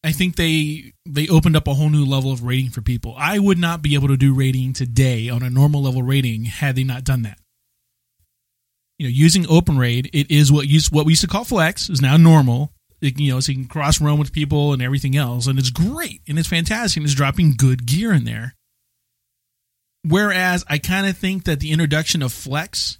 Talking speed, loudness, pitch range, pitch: 225 wpm, -17 LUFS, 130-160 Hz, 145 Hz